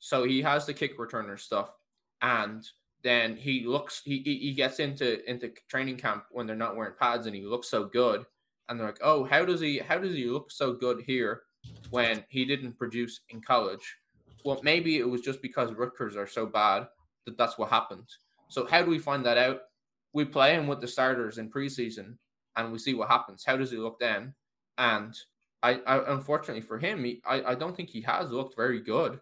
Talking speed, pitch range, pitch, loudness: 210 wpm, 120-140 Hz, 125 Hz, -29 LUFS